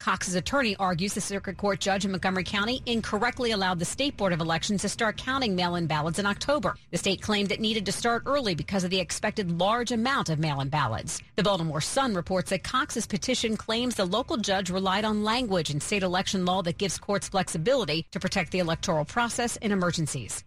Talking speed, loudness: 205 wpm, -27 LUFS